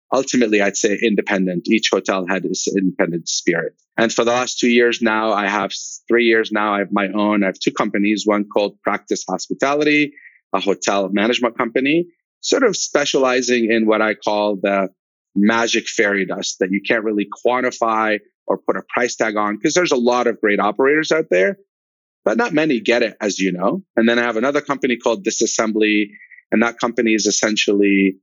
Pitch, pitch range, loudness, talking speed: 110 Hz, 100-120 Hz, -18 LUFS, 190 wpm